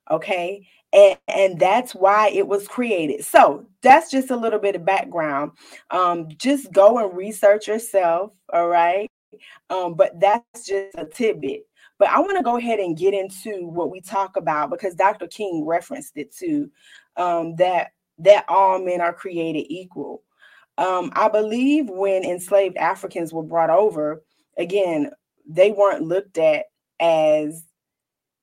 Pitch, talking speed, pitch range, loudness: 195 Hz, 150 wpm, 175-225 Hz, -20 LUFS